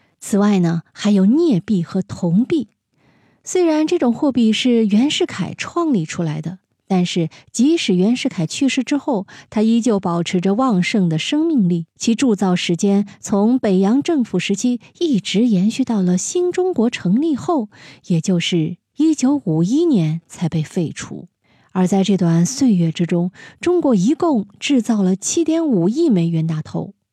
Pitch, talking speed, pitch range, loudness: 210 Hz, 235 characters per minute, 180-270 Hz, -18 LUFS